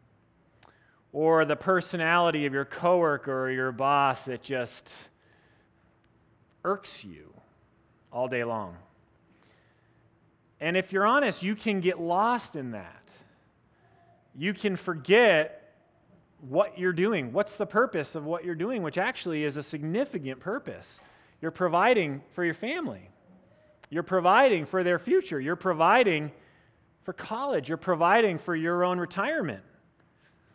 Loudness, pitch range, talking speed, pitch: -27 LUFS, 145-185 Hz, 130 wpm, 170 Hz